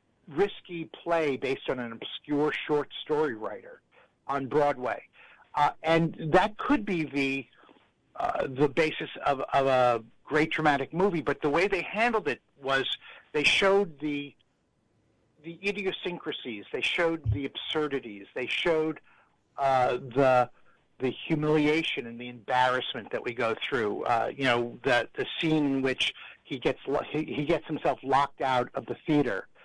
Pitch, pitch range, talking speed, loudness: 145 Hz, 130-165 Hz, 150 wpm, -28 LUFS